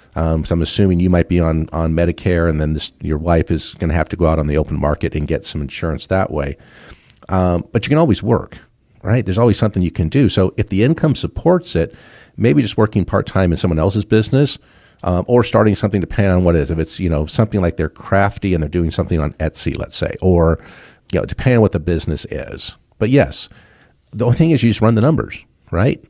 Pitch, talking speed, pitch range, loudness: 90 Hz, 240 wpm, 80-110 Hz, -17 LUFS